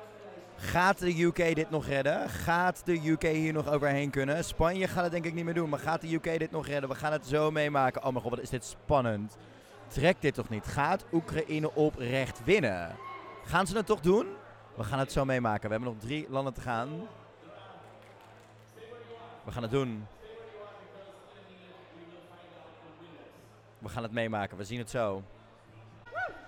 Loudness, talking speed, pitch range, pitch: -31 LUFS, 175 wpm, 115-165 Hz, 140 Hz